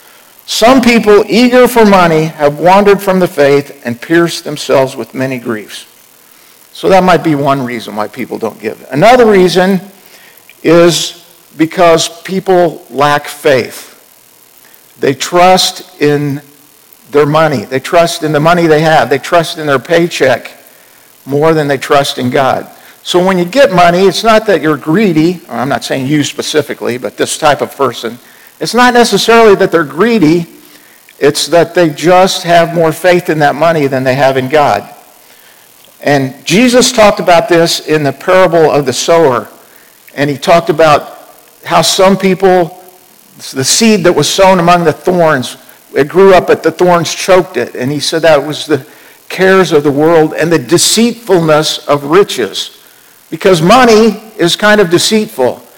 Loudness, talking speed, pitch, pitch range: -9 LUFS, 165 wpm, 170 Hz, 145-185 Hz